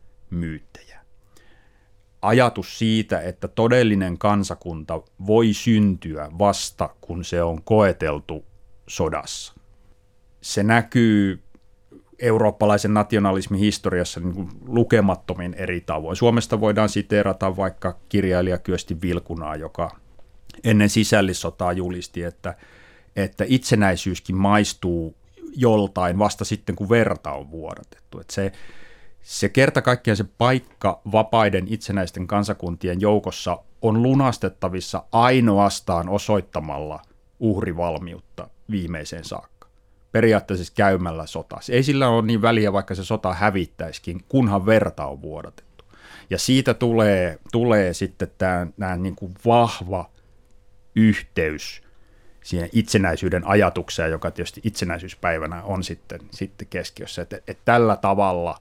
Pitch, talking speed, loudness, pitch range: 100 Hz, 105 wpm, -21 LUFS, 90-110 Hz